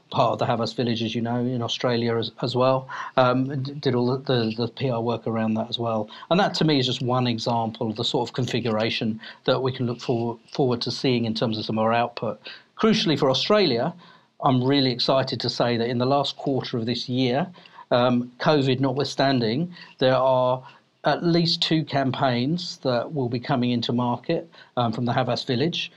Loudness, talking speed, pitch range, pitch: -24 LUFS, 205 wpm, 120-140 Hz, 125 Hz